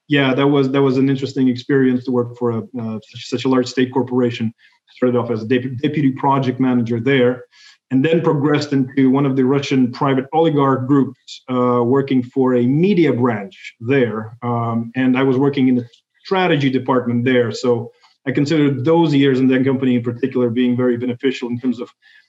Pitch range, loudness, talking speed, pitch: 125-135 Hz, -17 LUFS, 190 wpm, 130 Hz